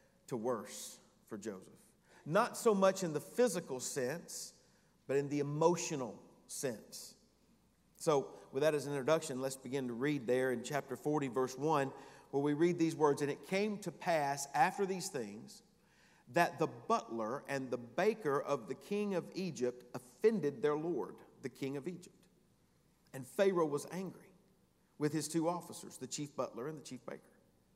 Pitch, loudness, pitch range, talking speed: 150 Hz, -37 LUFS, 140-180 Hz, 170 wpm